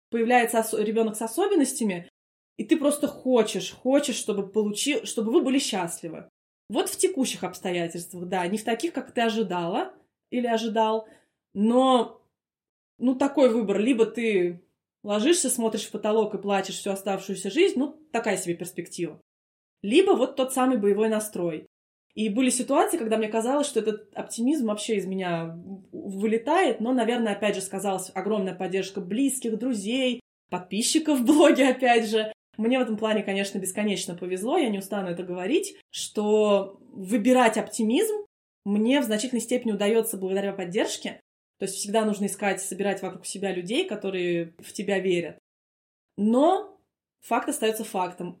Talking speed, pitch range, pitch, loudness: 150 wpm, 195-250 Hz, 215 Hz, -25 LUFS